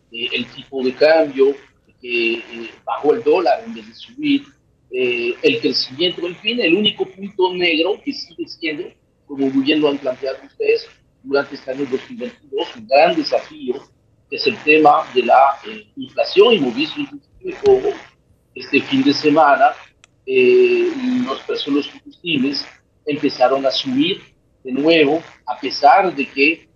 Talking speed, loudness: 150 wpm, -17 LUFS